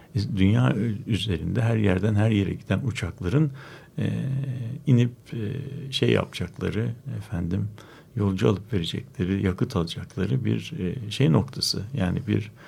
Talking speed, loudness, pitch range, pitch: 120 wpm, -26 LUFS, 100-130 Hz, 110 Hz